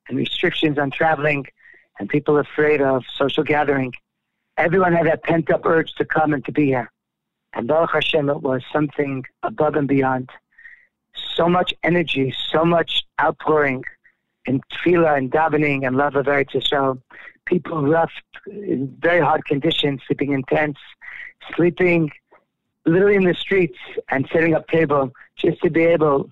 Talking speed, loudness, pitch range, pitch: 155 wpm, -19 LUFS, 140-165 Hz, 150 Hz